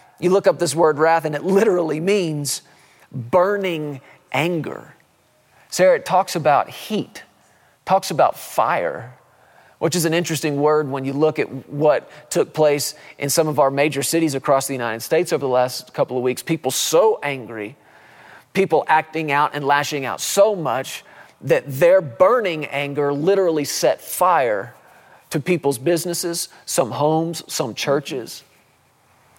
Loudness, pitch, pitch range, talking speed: -19 LUFS, 155 Hz, 140-175 Hz, 150 wpm